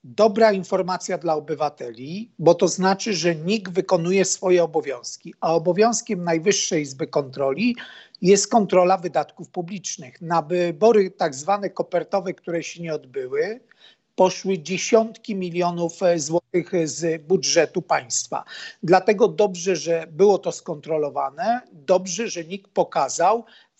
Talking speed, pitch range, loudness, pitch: 120 wpm, 165-200 Hz, -22 LUFS, 185 Hz